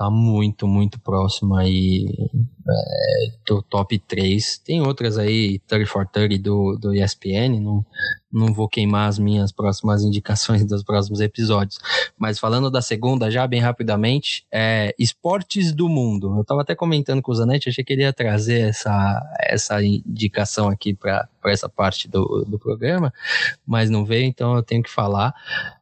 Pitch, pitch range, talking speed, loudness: 110 Hz, 100-120 Hz, 160 wpm, -20 LUFS